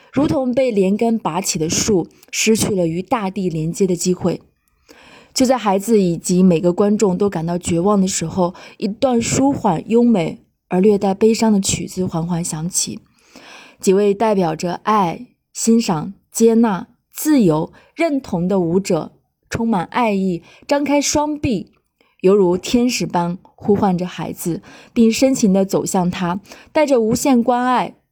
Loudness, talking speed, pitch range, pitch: -17 LUFS, 220 characters per minute, 180-235 Hz, 200 Hz